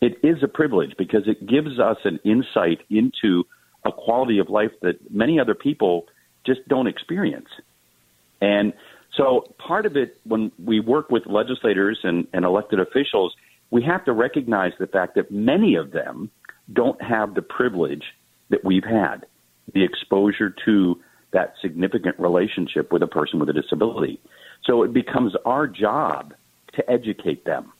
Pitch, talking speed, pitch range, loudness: 100 Hz, 160 wpm, 85-110 Hz, -21 LUFS